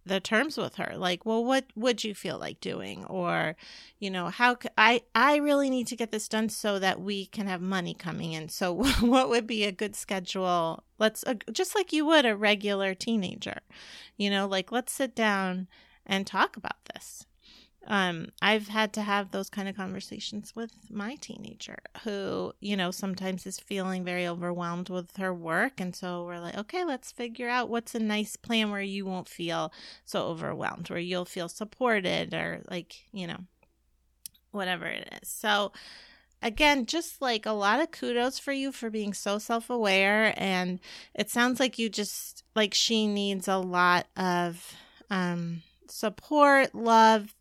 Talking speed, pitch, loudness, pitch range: 175 wpm, 205 Hz, -28 LUFS, 185-230 Hz